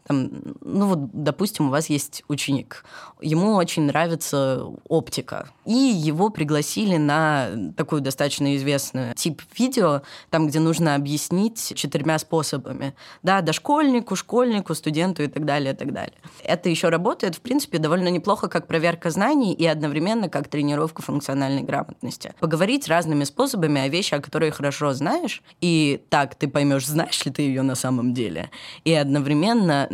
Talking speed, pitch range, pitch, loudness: 150 wpm, 145-175 Hz, 155 Hz, -22 LUFS